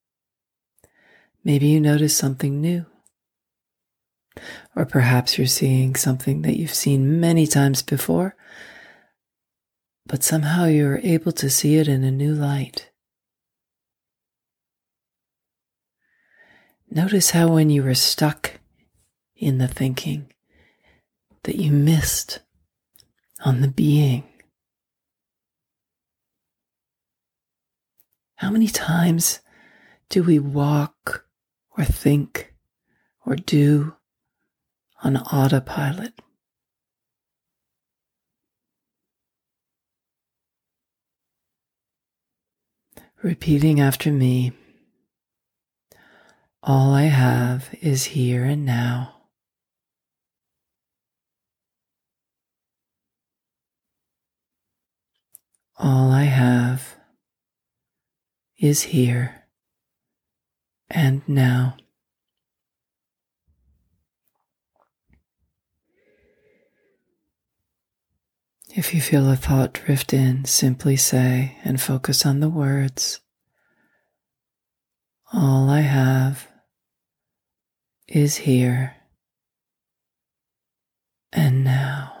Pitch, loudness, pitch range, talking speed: 140 Hz, -20 LUFS, 130-150 Hz, 65 wpm